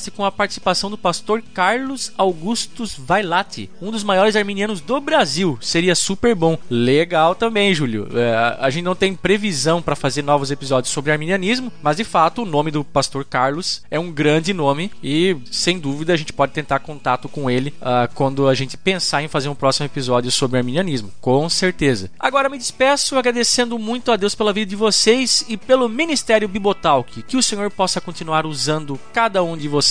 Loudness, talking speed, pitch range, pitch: -18 LUFS, 185 wpm, 140-215 Hz, 175 Hz